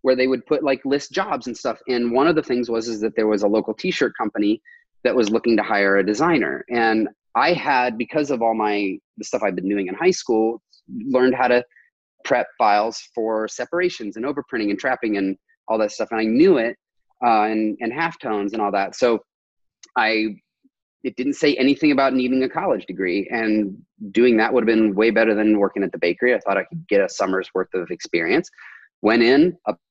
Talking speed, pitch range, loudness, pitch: 215 wpm, 110-135 Hz, -20 LUFS, 115 Hz